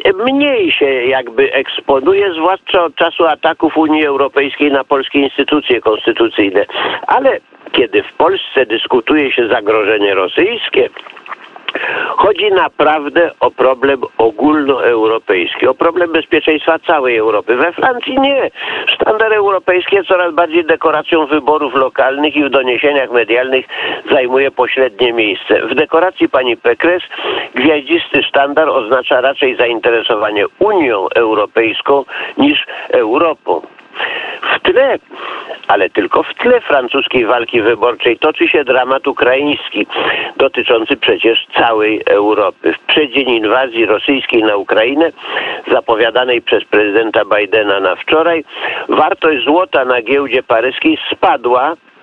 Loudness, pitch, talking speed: -12 LUFS, 165 Hz, 110 wpm